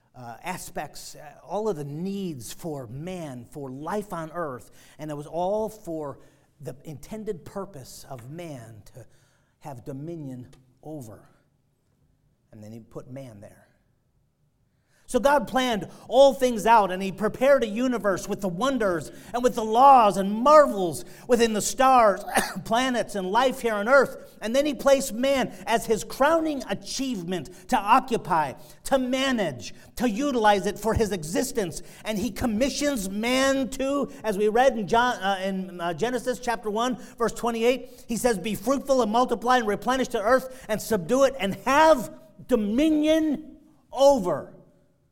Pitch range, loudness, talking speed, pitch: 160-250 Hz, -24 LUFS, 155 wpm, 210 Hz